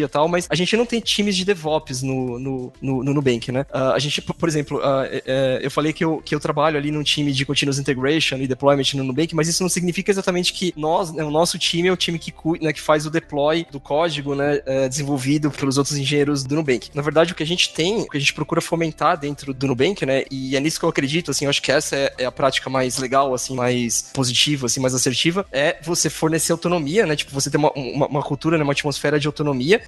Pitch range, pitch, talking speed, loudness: 135-165 Hz, 145 Hz, 245 wpm, -20 LUFS